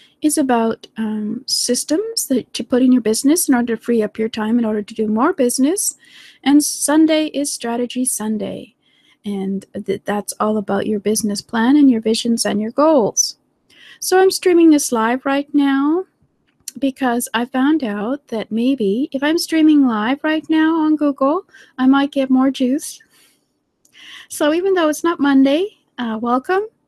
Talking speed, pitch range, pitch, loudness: 170 wpm, 225-300 Hz, 265 Hz, -17 LUFS